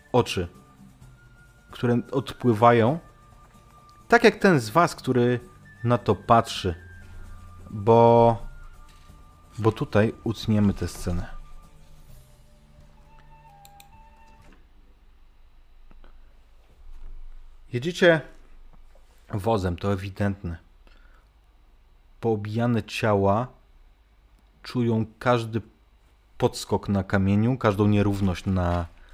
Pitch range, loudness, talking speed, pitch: 75-120 Hz, -23 LUFS, 65 wpm, 100 Hz